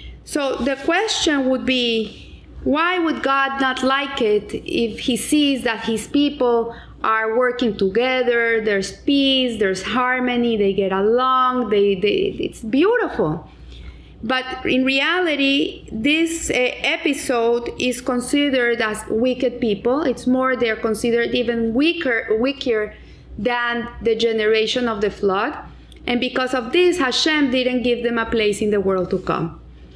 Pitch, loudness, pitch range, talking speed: 250 Hz, -19 LUFS, 225-270 Hz, 140 wpm